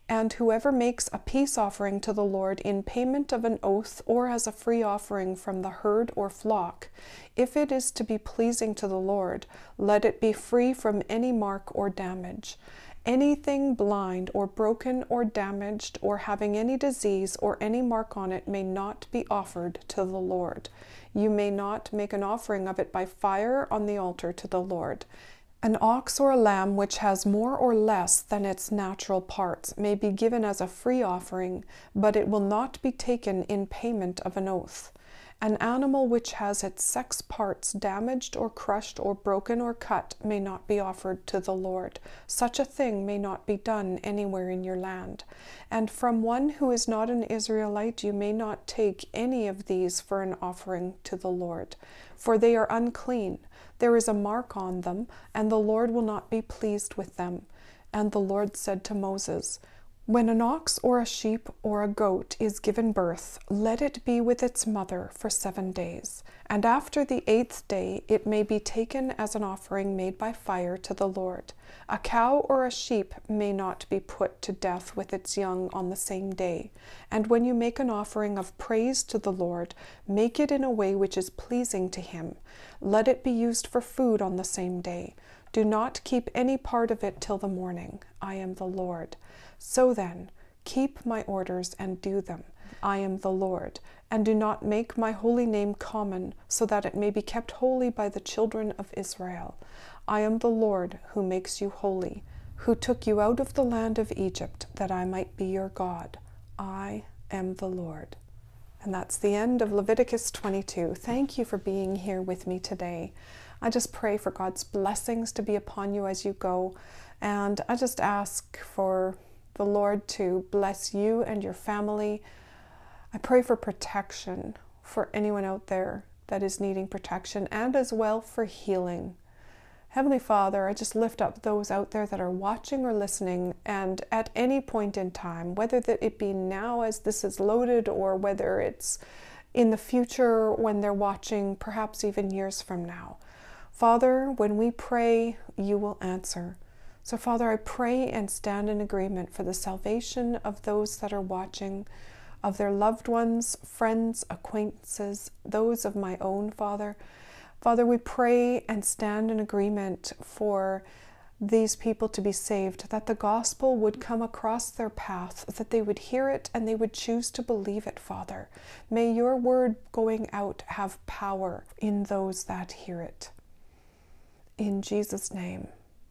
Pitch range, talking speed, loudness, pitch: 195-230 Hz, 180 wpm, -29 LUFS, 210 Hz